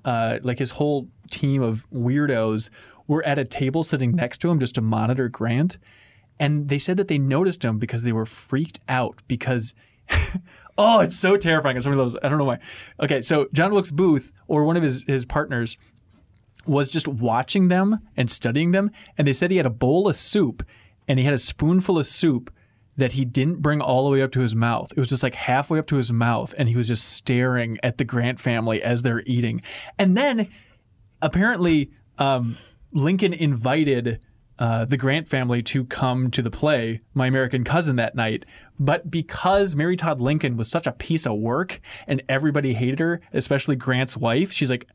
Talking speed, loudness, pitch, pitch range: 195 wpm, -22 LUFS, 135 Hz, 120-155 Hz